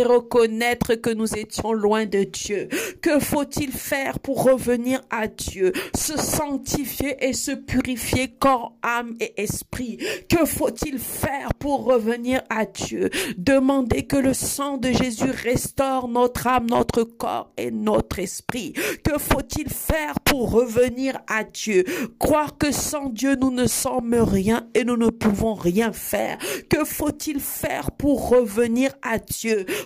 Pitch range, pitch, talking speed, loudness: 230-275 Hz, 250 Hz, 145 wpm, -22 LUFS